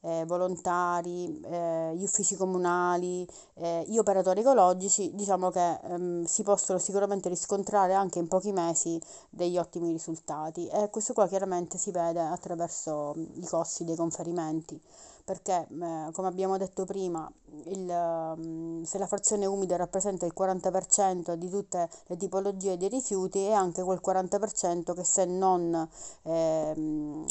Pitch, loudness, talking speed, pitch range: 180 Hz, -29 LUFS, 140 wpm, 170-195 Hz